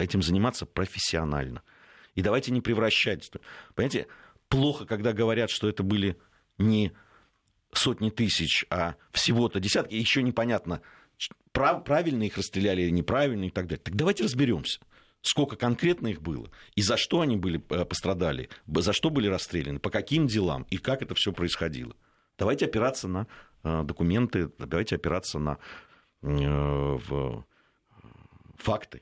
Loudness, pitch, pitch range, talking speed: -28 LUFS, 100 Hz, 85-115 Hz, 130 wpm